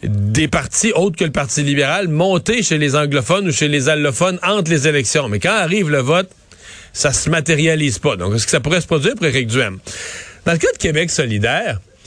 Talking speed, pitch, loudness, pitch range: 220 wpm, 150 Hz, -16 LUFS, 135-170 Hz